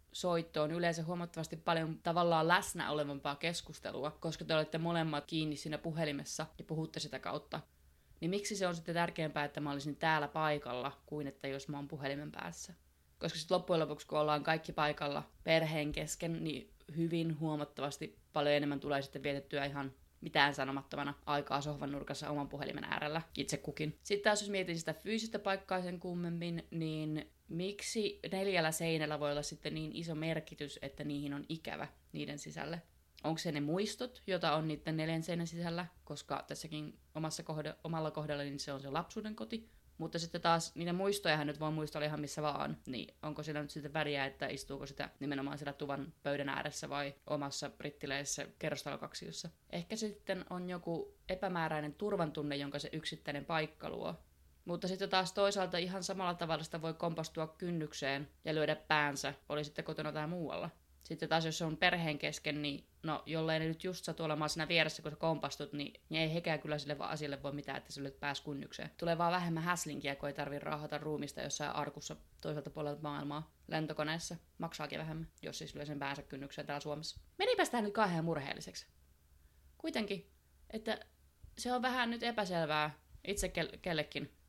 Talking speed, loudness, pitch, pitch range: 175 wpm, -39 LUFS, 155 Hz, 145-170 Hz